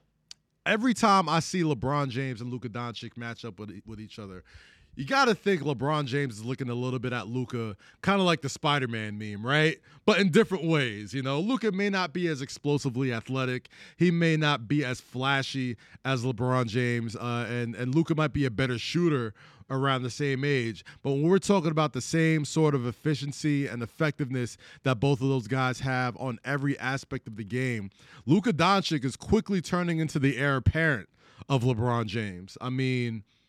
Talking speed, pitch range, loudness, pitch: 195 wpm, 120-155 Hz, -28 LUFS, 135 Hz